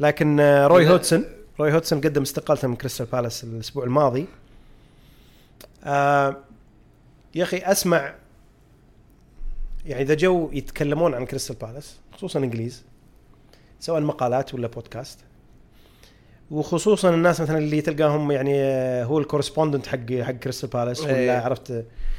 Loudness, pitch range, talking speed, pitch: -22 LUFS, 125-155 Hz, 115 wpm, 140 Hz